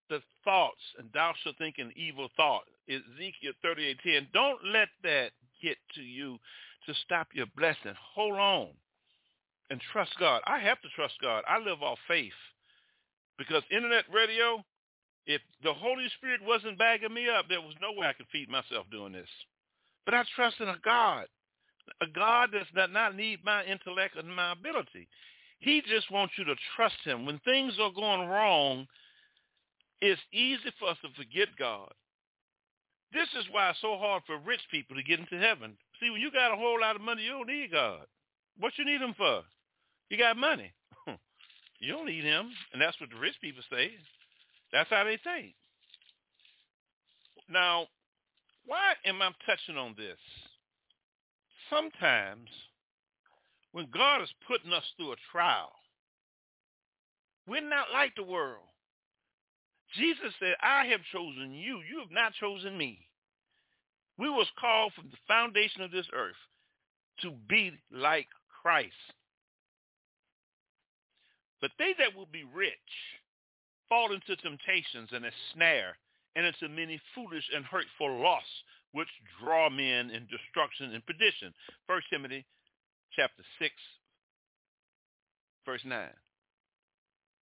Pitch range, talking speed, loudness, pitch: 160-235 Hz, 150 wpm, -30 LUFS, 200 Hz